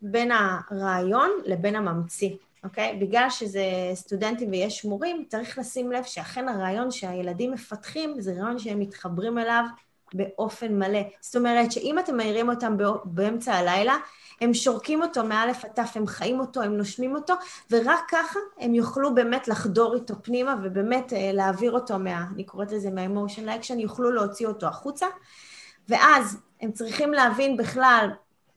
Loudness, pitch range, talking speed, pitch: -25 LUFS, 200-250 Hz, 150 wpm, 225 Hz